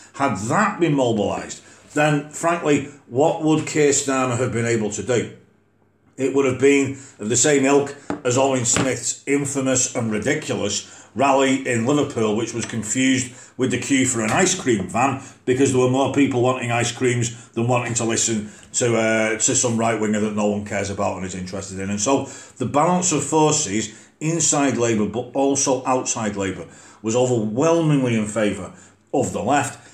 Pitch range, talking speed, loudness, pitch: 110-140 Hz, 180 wpm, -20 LUFS, 125 Hz